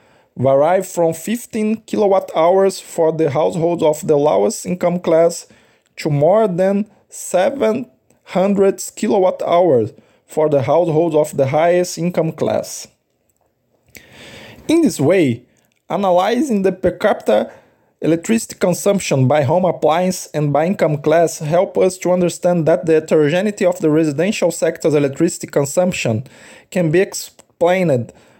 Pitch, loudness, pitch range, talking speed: 170 Hz, -16 LUFS, 155-190 Hz, 125 wpm